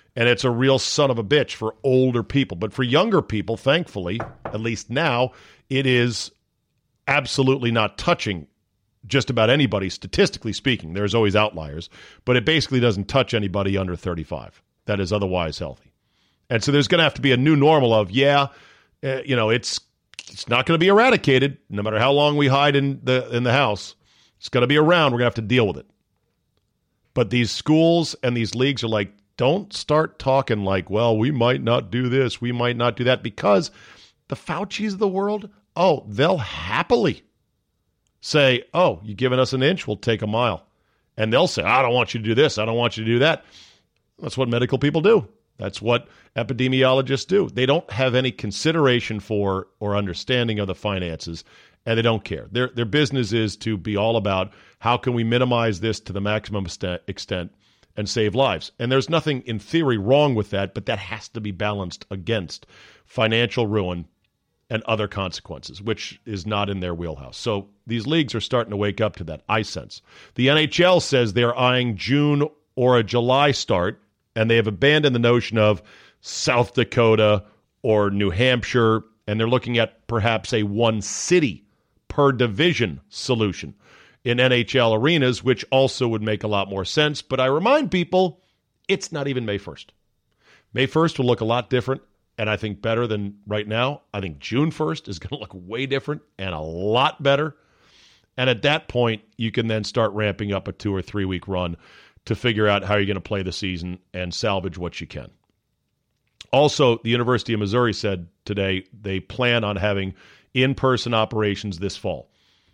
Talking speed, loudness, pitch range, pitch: 190 wpm, -21 LUFS, 105-130 Hz, 115 Hz